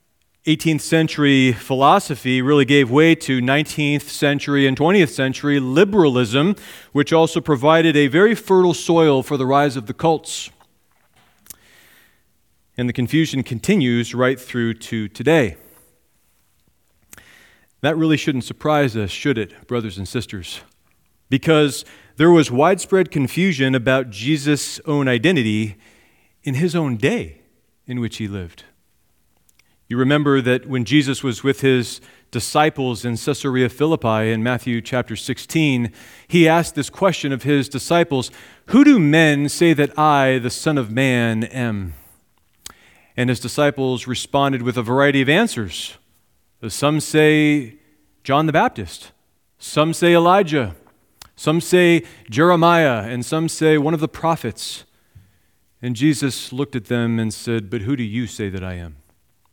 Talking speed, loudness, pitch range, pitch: 140 wpm, -18 LUFS, 120-155 Hz, 135 Hz